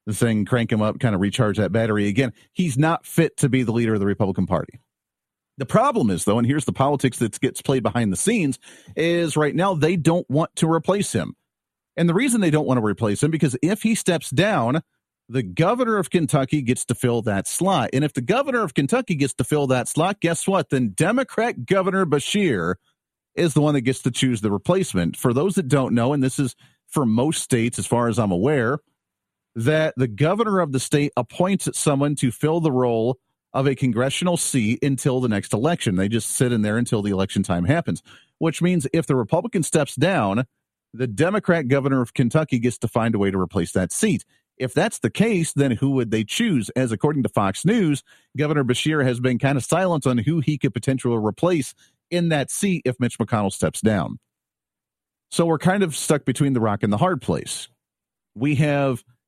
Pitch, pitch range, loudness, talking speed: 135 Hz, 120-165 Hz, -21 LUFS, 210 wpm